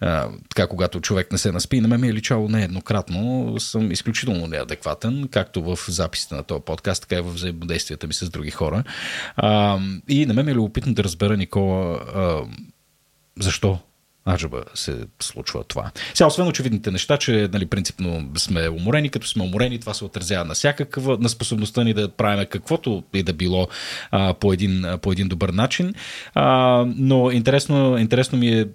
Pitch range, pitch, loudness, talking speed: 95-120 Hz, 105 Hz, -21 LUFS, 175 wpm